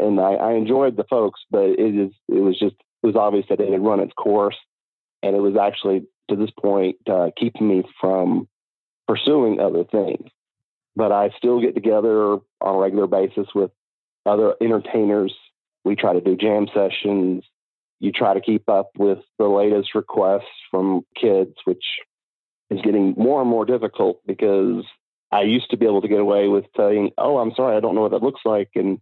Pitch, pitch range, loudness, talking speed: 100 Hz, 95-110 Hz, -20 LUFS, 190 wpm